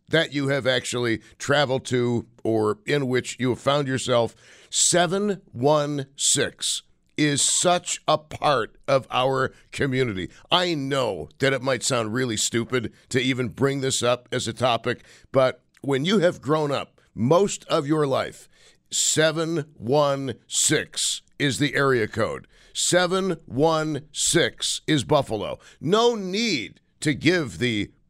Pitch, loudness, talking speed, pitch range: 135 Hz, -23 LUFS, 130 wpm, 125-155 Hz